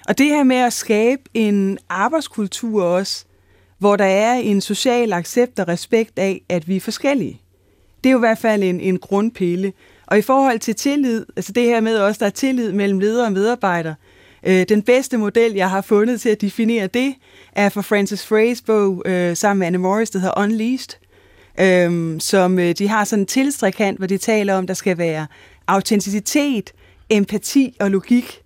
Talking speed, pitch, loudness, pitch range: 190 wpm, 205 Hz, -18 LUFS, 190-230 Hz